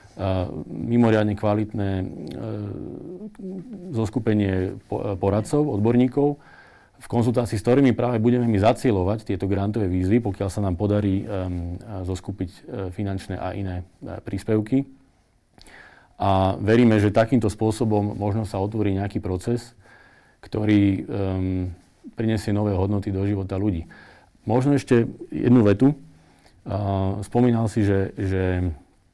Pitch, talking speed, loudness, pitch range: 105 Hz, 120 wpm, -23 LUFS, 95-120 Hz